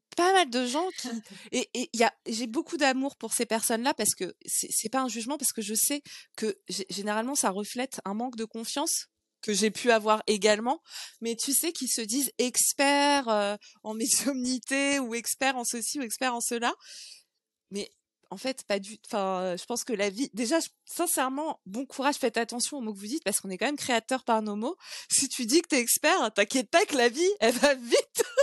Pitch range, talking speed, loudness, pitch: 220-280 Hz, 225 wpm, -27 LUFS, 245 Hz